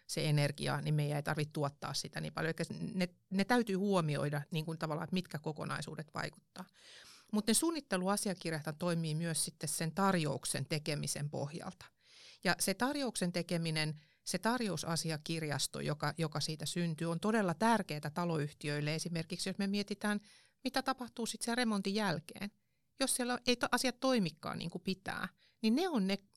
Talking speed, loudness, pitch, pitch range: 155 wpm, -36 LUFS, 175 Hz, 155-210 Hz